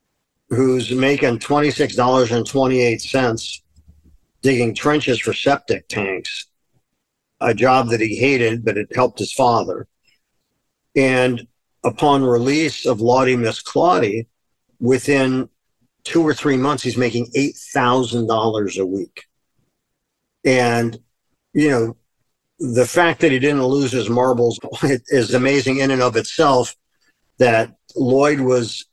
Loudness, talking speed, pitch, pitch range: -18 LUFS, 115 wpm, 125 Hz, 115-135 Hz